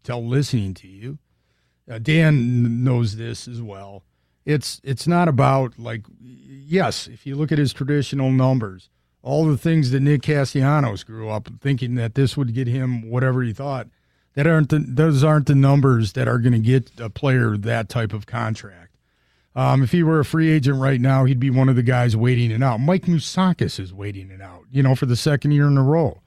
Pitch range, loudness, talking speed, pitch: 115-140 Hz, -19 LUFS, 210 wpm, 130 Hz